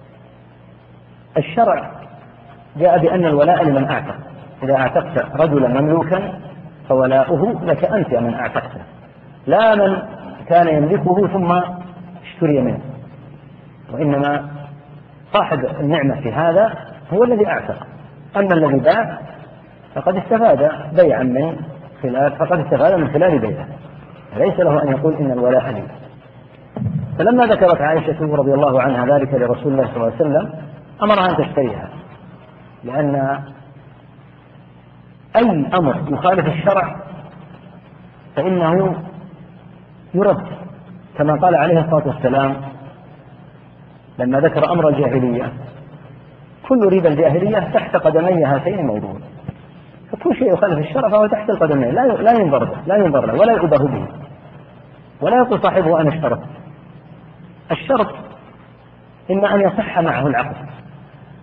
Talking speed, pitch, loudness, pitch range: 115 wpm, 150 Hz, -16 LUFS, 140-175 Hz